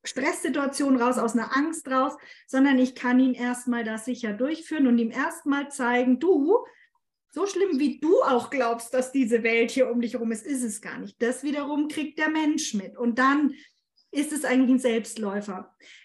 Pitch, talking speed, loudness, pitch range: 260 Hz, 185 wpm, -25 LUFS, 240-295 Hz